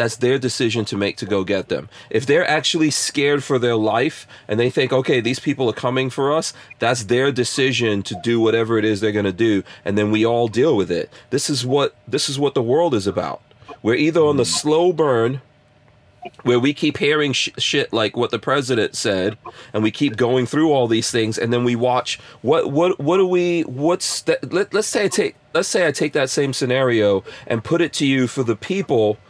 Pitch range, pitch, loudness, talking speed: 115-145 Hz, 125 Hz, -19 LUFS, 225 wpm